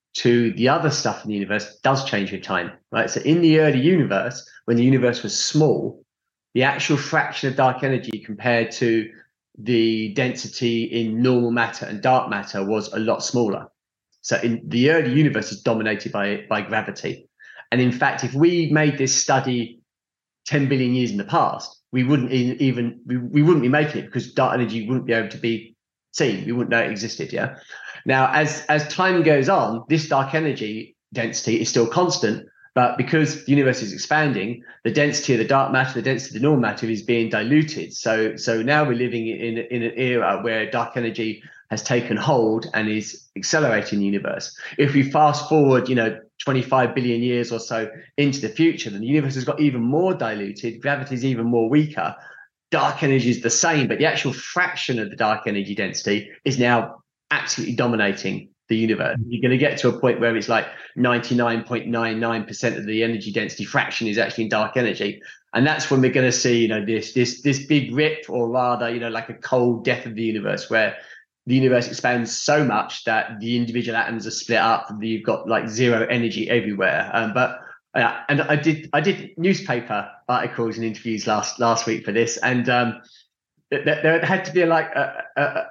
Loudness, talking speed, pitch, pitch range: -21 LUFS, 200 wpm, 120 Hz, 115-135 Hz